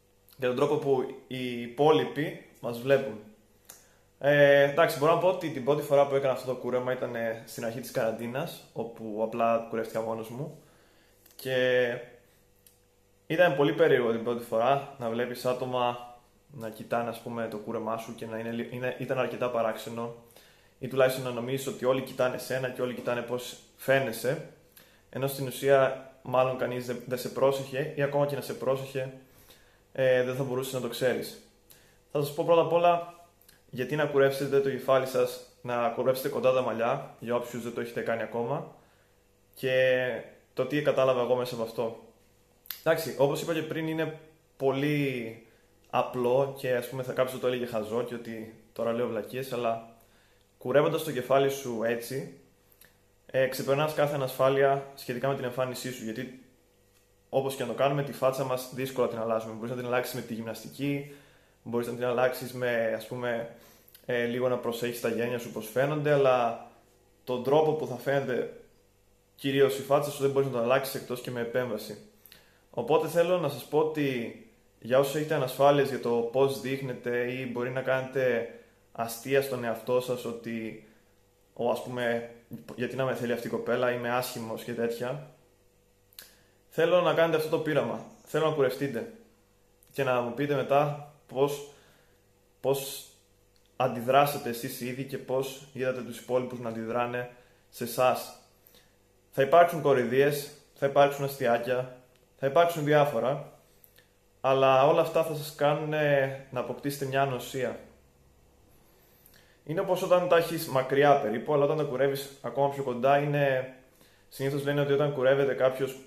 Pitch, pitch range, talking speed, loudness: 125 Hz, 115-140 Hz, 165 wpm, -29 LUFS